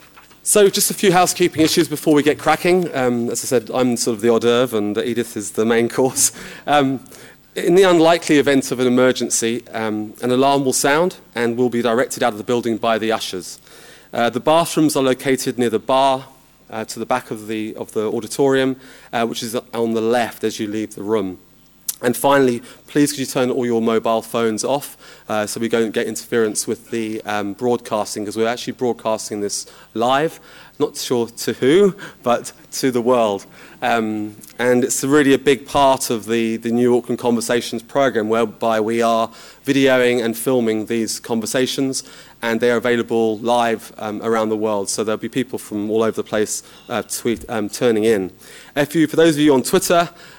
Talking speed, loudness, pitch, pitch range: 195 wpm, -18 LUFS, 120 Hz, 115-135 Hz